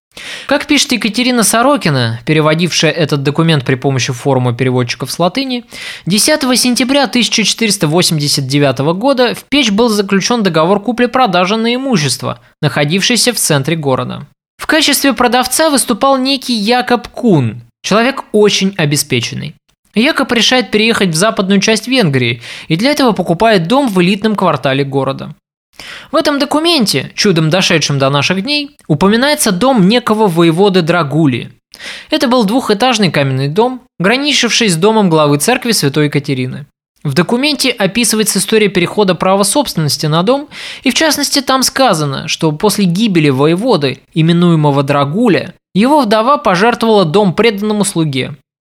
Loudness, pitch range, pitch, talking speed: -11 LUFS, 155-245 Hz, 205 Hz, 130 wpm